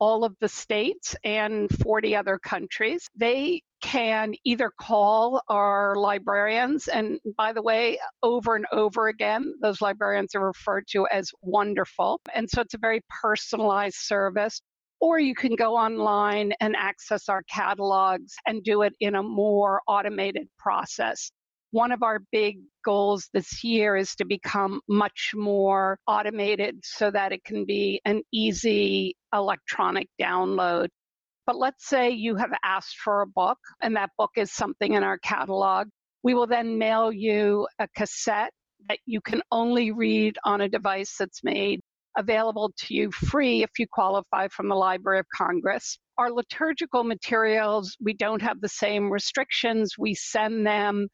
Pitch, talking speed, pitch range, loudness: 210 Hz, 155 wpm, 200-225 Hz, -25 LUFS